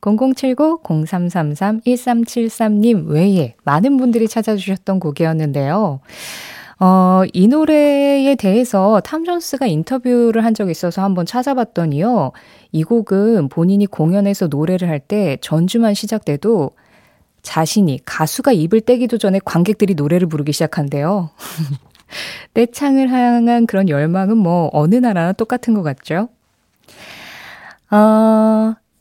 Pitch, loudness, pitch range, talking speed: 205 Hz, -15 LUFS, 170-235 Hz, 250 characters per minute